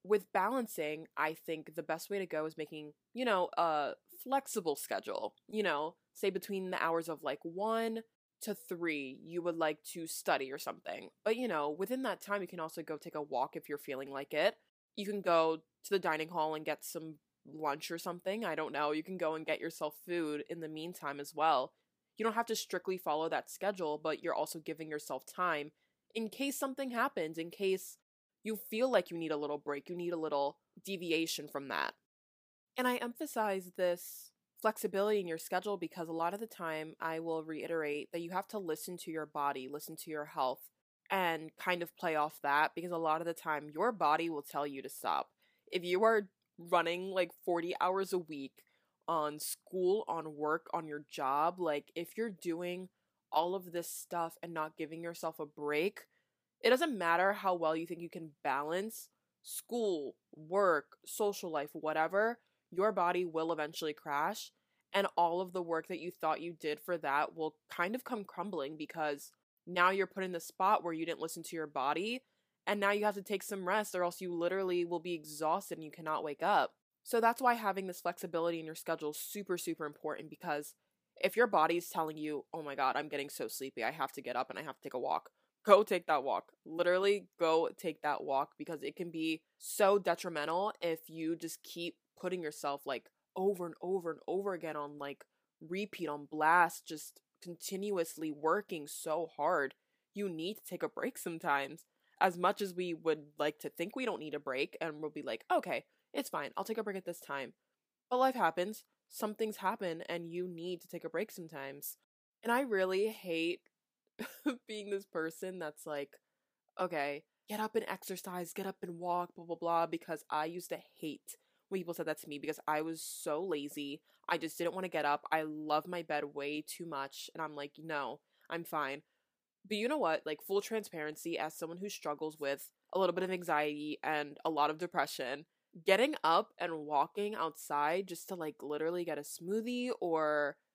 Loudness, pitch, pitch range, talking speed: -37 LUFS, 170 Hz, 155-190 Hz, 205 wpm